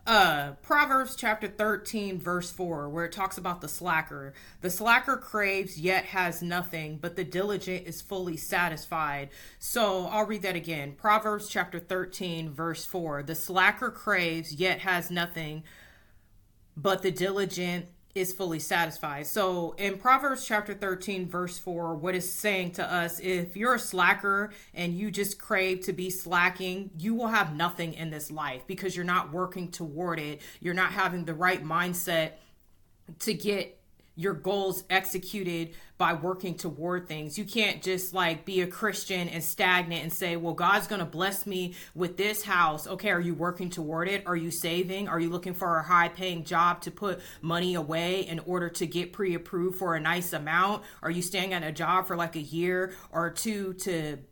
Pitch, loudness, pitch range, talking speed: 180 Hz, -29 LUFS, 165-190 Hz, 180 wpm